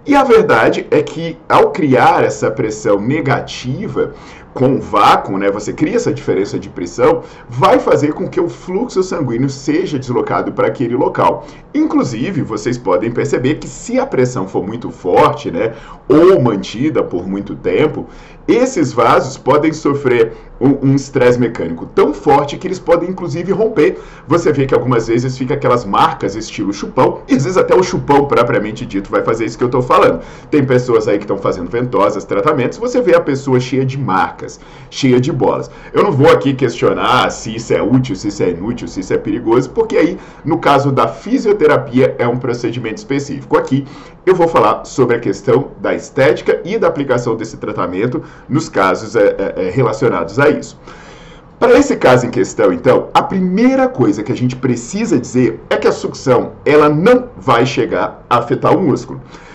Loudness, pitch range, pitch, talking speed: -14 LUFS, 125-200 Hz, 145 Hz, 185 wpm